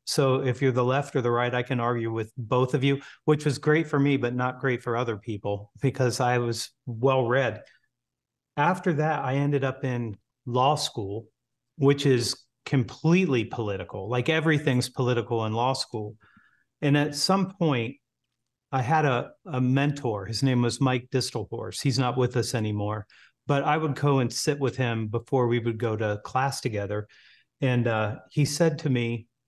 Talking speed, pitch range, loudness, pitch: 180 wpm, 115-140 Hz, -26 LUFS, 125 Hz